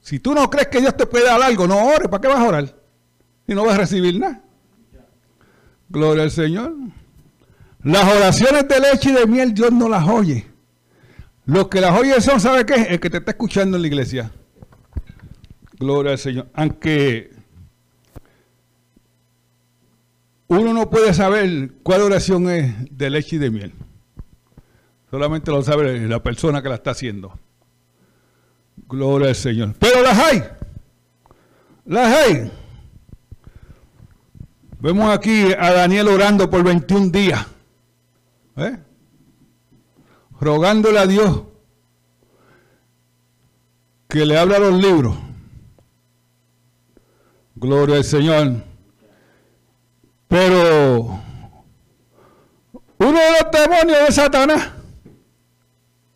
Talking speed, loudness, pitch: 120 wpm, -15 LUFS, 150 Hz